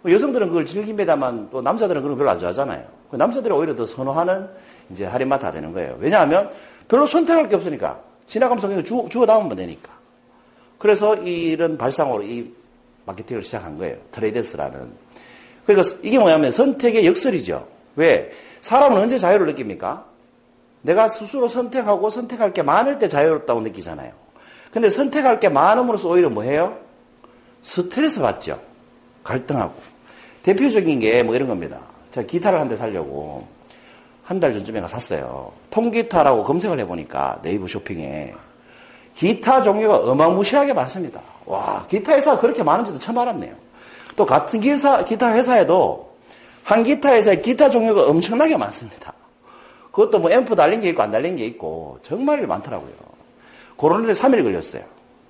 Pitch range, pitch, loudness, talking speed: 180-265 Hz, 225 Hz, -18 LUFS, 360 characters per minute